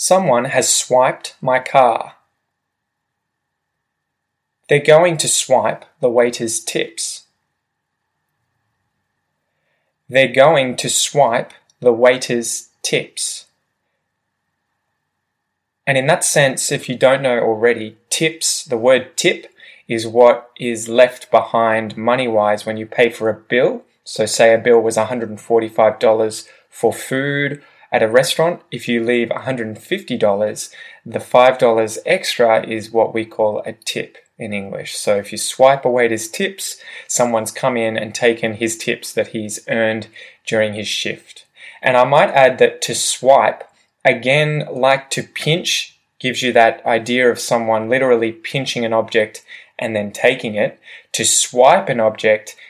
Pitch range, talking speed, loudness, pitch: 110-130 Hz, 135 wpm, -16 LUFS, 120 Hz